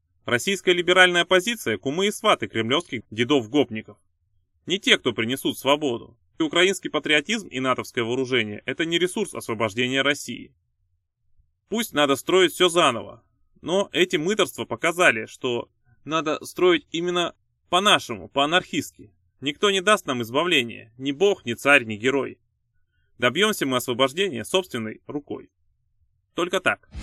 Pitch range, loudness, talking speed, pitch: 115-180 Hz, -22 LUFS, 125 wpm, 140 Hz